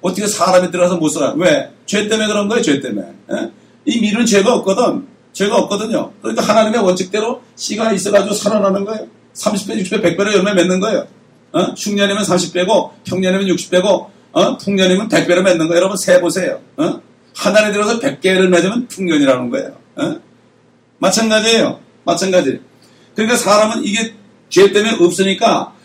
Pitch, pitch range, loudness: 205 Hz, 185-220 Hz, -14 LUFS